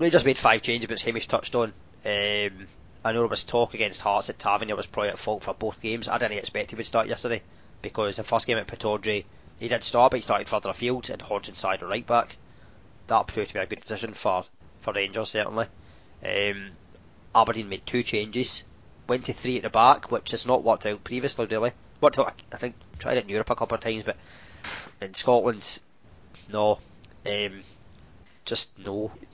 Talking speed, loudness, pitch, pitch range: 205 wpm, -26 LUFS, 110 Hz, 100-120 Hz